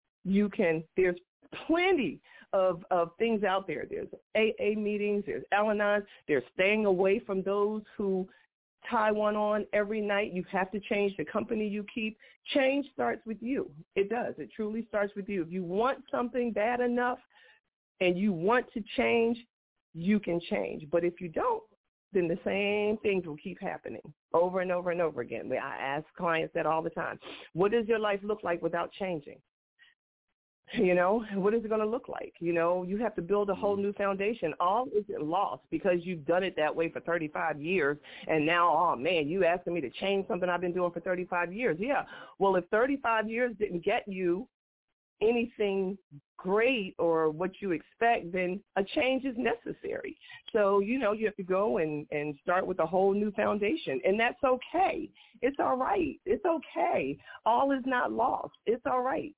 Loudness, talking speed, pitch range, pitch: -30 LUFS, 190 wpm, 180-235 Hz, 205 Hz